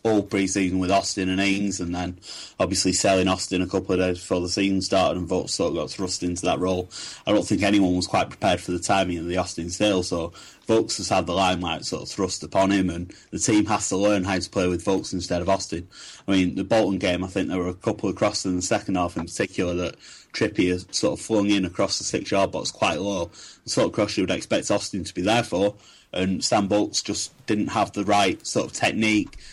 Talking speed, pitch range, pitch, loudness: 250 wpm, 90-100 Hz, 95 Hz, -24 LUFS